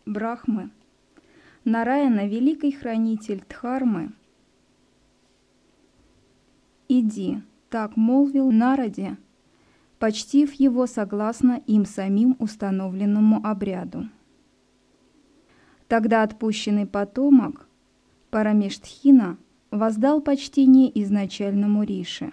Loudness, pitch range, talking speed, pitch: -22 LUFS, 210-255 Hz, 65 wpm, 225 Hz